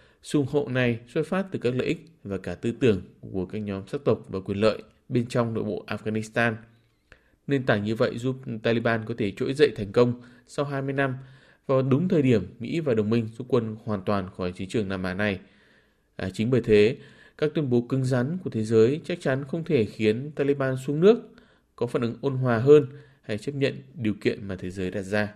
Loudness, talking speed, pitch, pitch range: -26 LUFS, 225 wpm, 120 Hz, 105-140 Hz